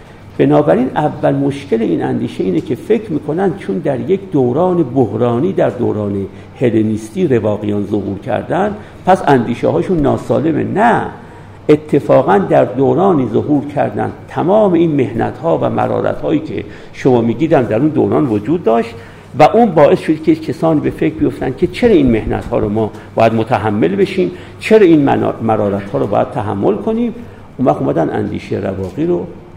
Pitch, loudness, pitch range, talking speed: 135 Hz, -14 LUFS, 110-180 Hz, 155 wpm